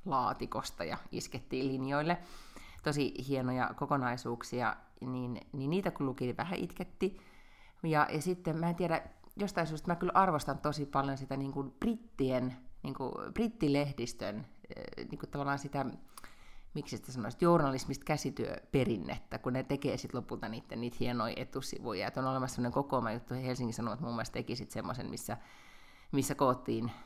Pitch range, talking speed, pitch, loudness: 125-155 Hz, 150 wpm, 140 Hz, -36 LUFS